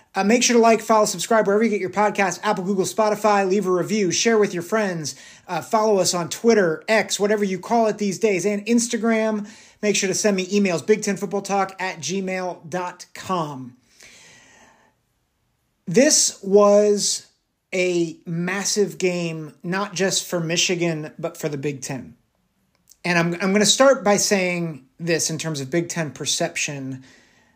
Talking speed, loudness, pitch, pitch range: 165 wpm, -20 LUFS, 190 Hz, 170-210 Hz